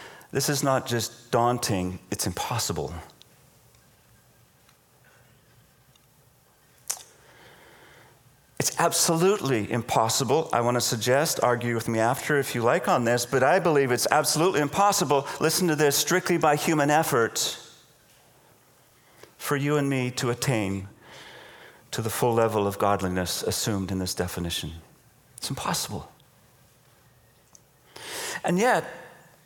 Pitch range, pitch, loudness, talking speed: 115-150 Hz, 130 Hz, -25 LUFS, 115 wpm